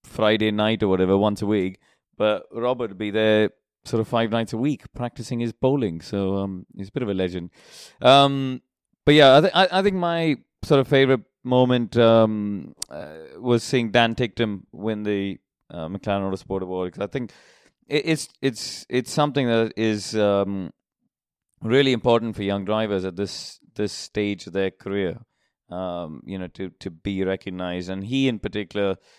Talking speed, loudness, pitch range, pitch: 175 wpm, -22 LUFS, 95-125 Hz, 110 Hz